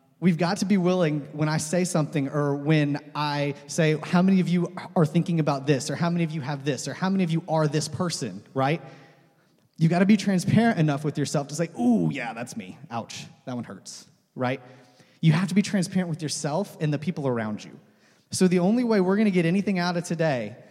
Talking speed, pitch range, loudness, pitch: 230 wpm, 145-180 Hz, -25 LUFS, 160 Hz